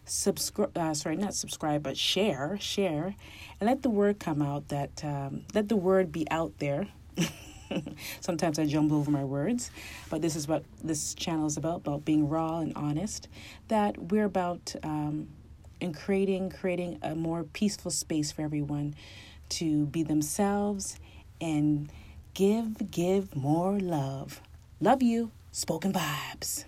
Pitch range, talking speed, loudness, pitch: 150-195 Hz, 150 wpm, -30 LUFS, 160 Hz